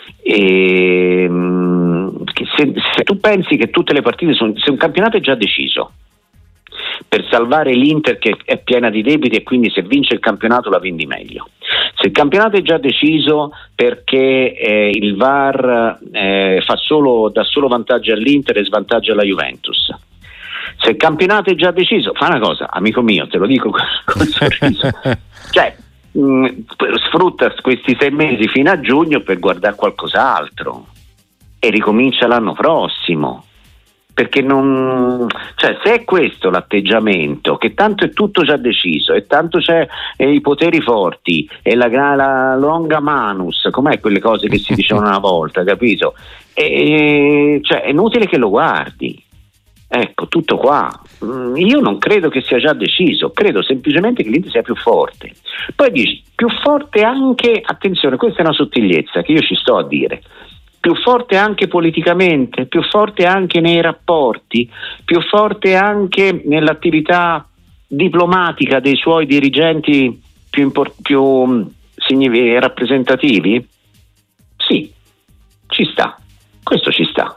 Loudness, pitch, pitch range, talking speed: -13 LUFS, 140 Hz, 115-180 Hz, 145 wpm